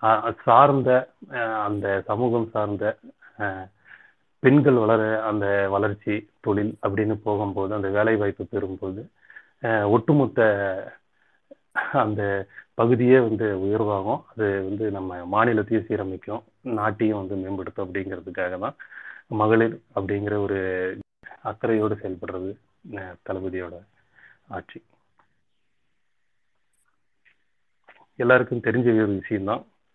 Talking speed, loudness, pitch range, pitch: 80 wpm, -23 LUFS, 100-110 Hz, 105 Hz